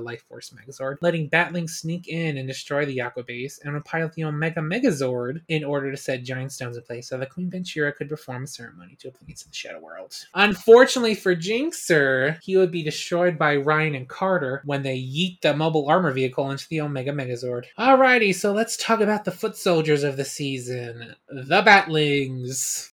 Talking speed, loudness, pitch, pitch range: 195 wpm, -22 LUFS, 150 Hz, 130-180 Hz